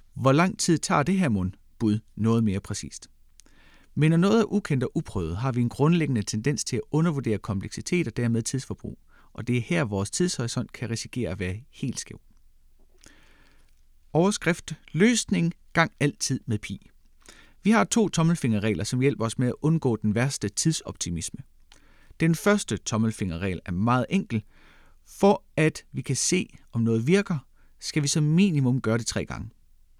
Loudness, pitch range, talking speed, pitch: -25 LUFS, 105-165 Hz, 165 wpm, 125 Hz